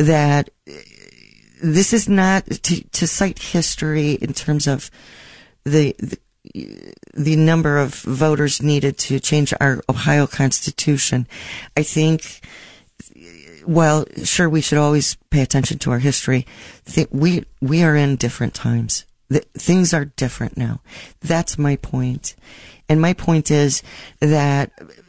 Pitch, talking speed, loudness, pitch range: 150 Hz, 130 wpm, -18 LUFS, 135-160 Hz